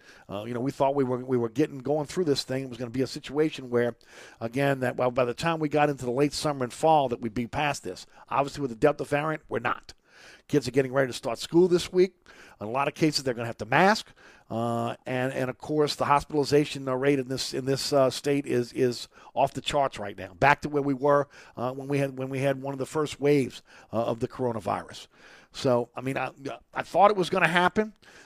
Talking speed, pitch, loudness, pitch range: 260 wpm, 135 Hz, -27 LUFS, 125-145 Hz